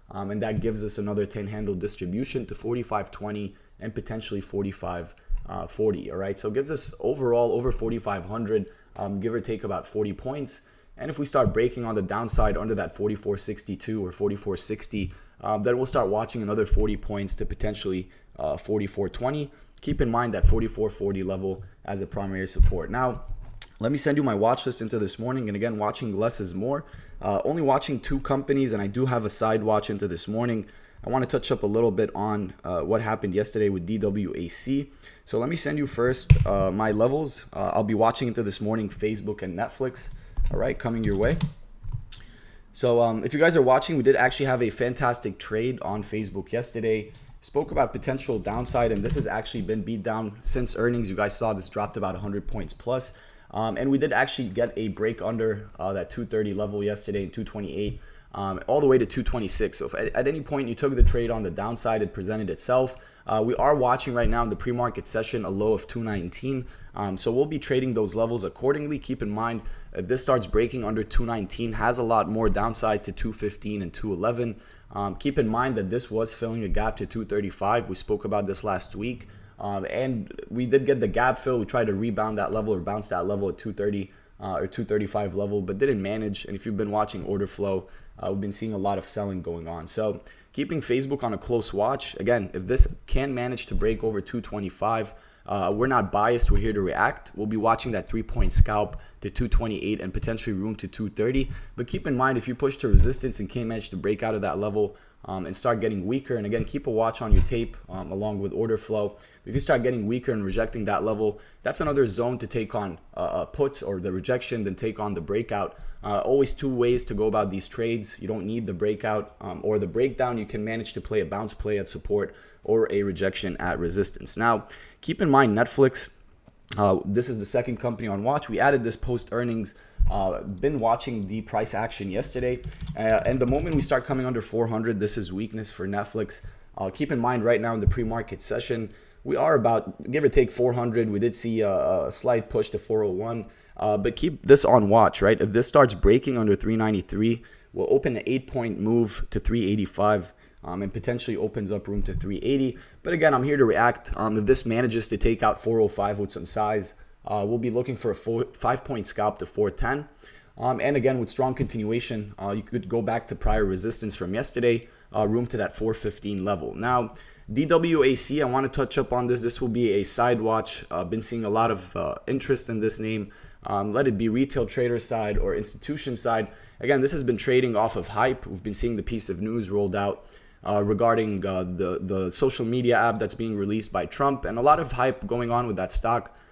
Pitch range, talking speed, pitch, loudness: 105-120 Hz, 215 wpm, 110 Hz, -26 LUFS